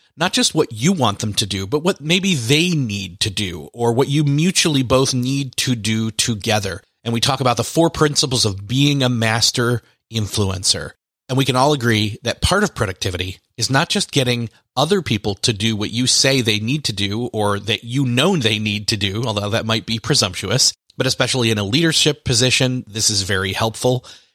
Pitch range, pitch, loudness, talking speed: 110-140 Hz, 120 Hz, -18 LUFS, 205 wpm